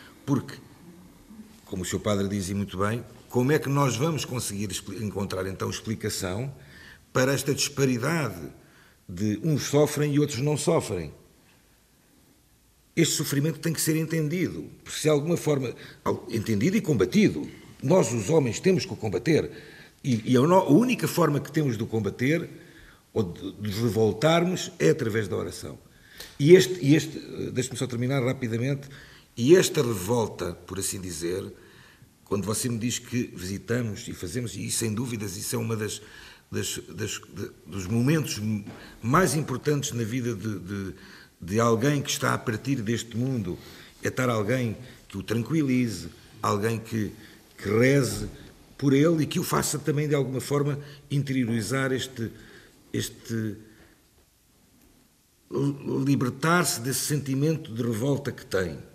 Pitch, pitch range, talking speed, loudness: 125 Hz, 110-145 Hz, 150 wpm, -26 LUFS